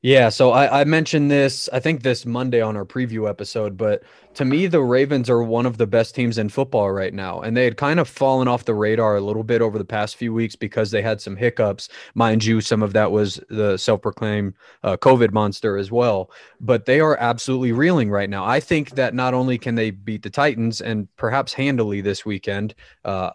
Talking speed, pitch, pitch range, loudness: 225 wpm, 115 Hz, 105-130 Hz, -20 LUFS